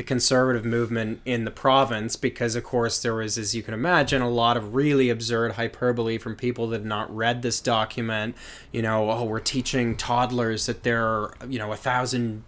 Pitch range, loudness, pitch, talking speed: 110-125 Hz, -24 LUFS, 120 Hz, 200 wpm